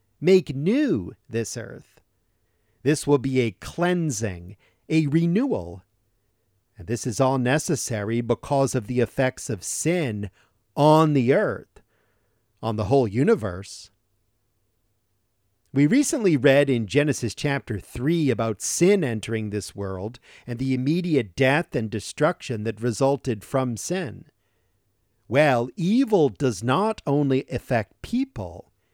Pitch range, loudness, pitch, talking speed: 105-145 Hz, -23 LUFS, 120 Hz, 120 wpm